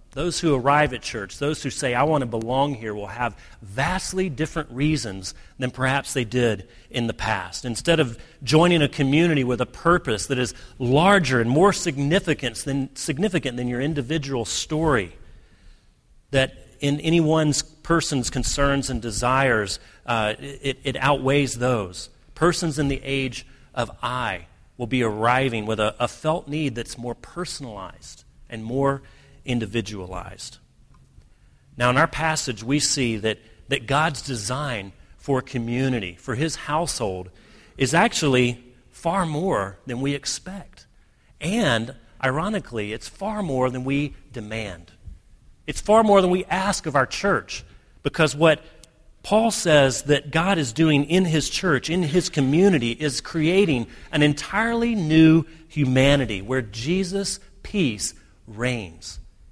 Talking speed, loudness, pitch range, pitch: 140 wpm, -22 LUFS, 120-155 Hz, 135 Hz